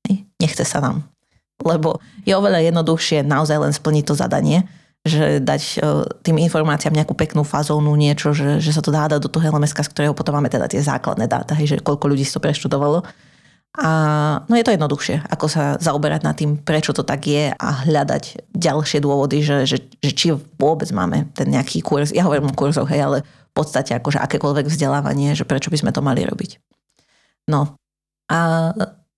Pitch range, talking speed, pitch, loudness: 145-160 Hz, 185 wpm, 150 Hz, -18 LUFS